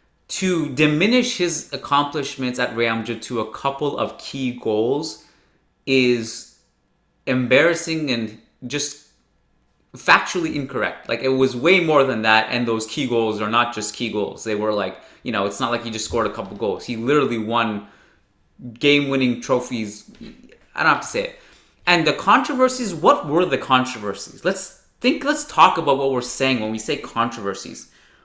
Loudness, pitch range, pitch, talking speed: -20 LUFS, 115-150 Hz, 130 Hz, 170 wpm